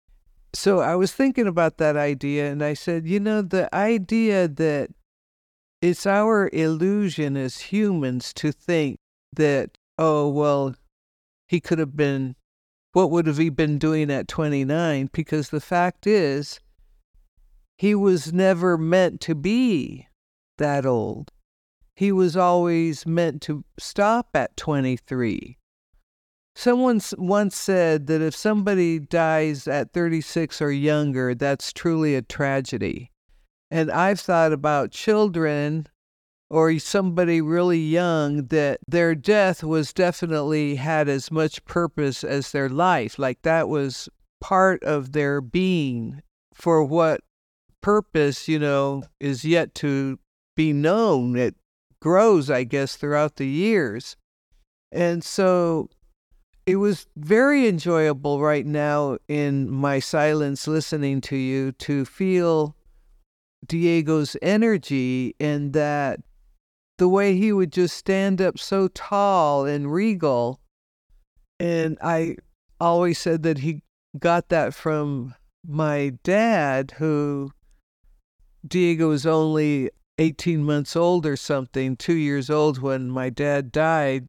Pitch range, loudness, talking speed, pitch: 140-175 Hz, -22 LUFS, 125 wpm, 155 Hz